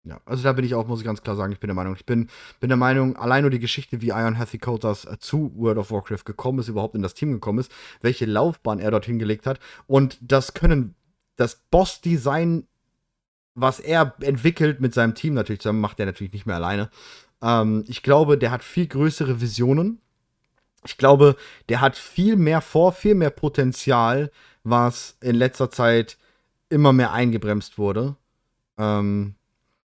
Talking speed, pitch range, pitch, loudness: 185 wpm, 110-140 Hz, 125 Hz, -21 LUFS